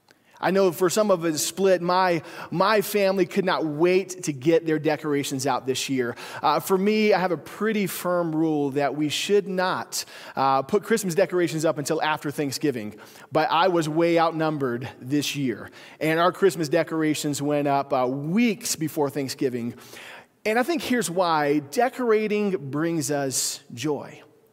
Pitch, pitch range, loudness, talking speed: 160 Hz, 145-190 Hz, -24 LUFS, 165 wpm